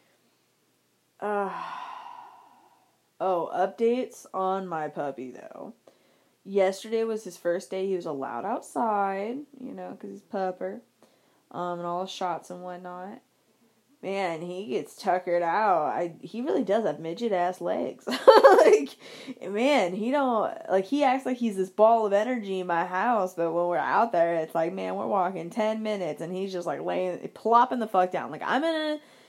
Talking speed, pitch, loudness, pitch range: 170 wpm, 190 Hz, -26 LUFS, 175-230 Hz